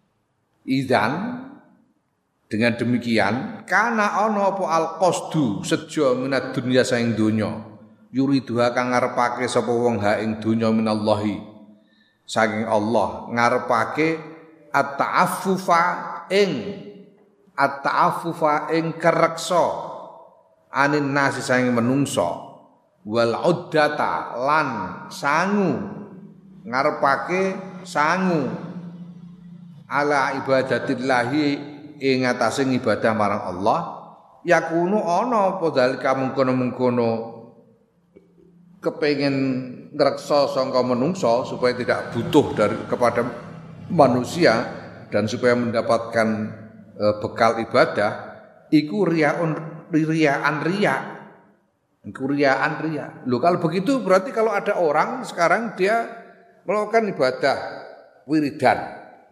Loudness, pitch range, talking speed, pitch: -21 LUFS, 120-175 Hz, 90 wpm, 145 Hz